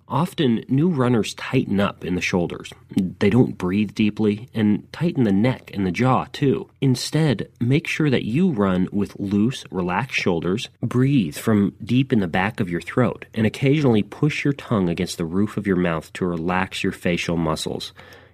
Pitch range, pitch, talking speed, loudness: 95-130 Hz, 105 Hz, 180 wpm, -21 LUFS